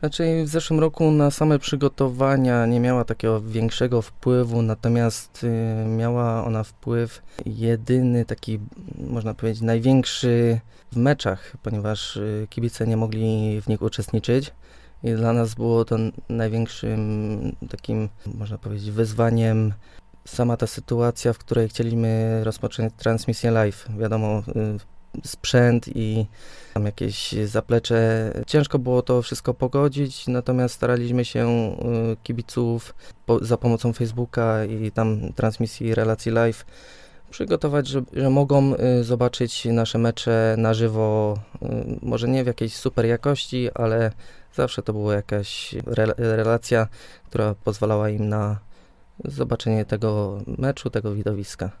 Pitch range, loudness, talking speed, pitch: 110-125 Hz, -23 LUFS, 120 wpm, 115 Hz